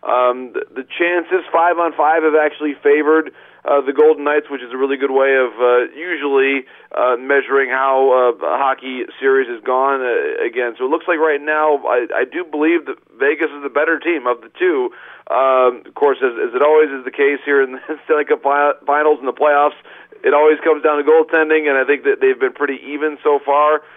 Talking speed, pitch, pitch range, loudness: 225 wpm, 150 Hz, 135-170 Hz, -16 LUFS